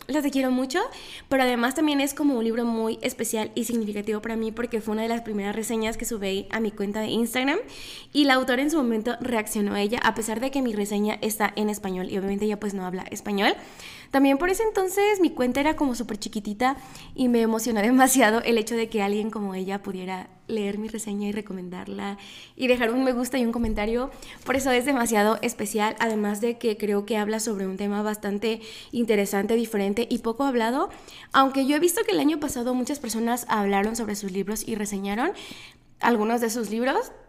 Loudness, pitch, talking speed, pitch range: -25 LUFS, 225 Hz, 210 wpm, 210-255 Hz